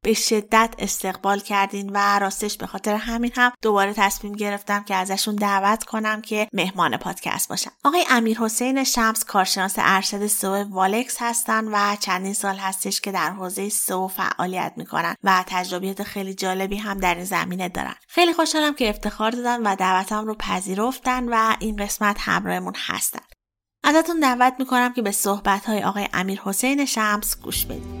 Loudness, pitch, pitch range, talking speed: -22 LUFS, 205 Hz, 190-225 Hz, 165 wpm